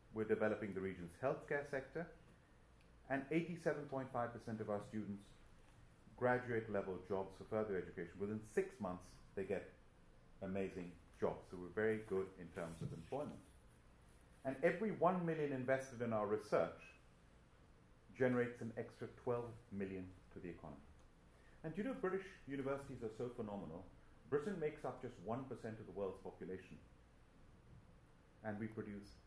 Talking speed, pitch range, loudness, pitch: 140 wpm, 95-135 Hz, -44 LUFS, 110 Hz